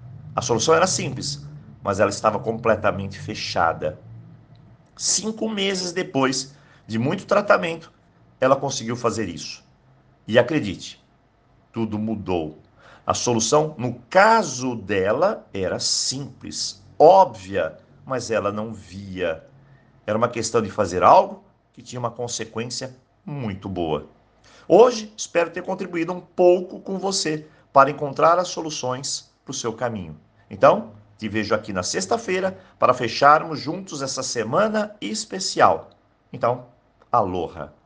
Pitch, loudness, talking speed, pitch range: 130 Hz, -22 LUFS, 120 wpm, 110-155 Hz